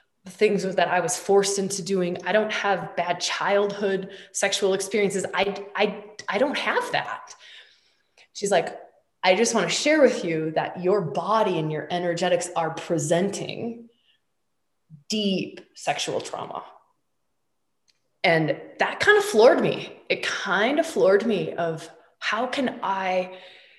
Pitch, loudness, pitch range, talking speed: 195 Hz, -24 LUFS, 175-210 Hz, 140 wpm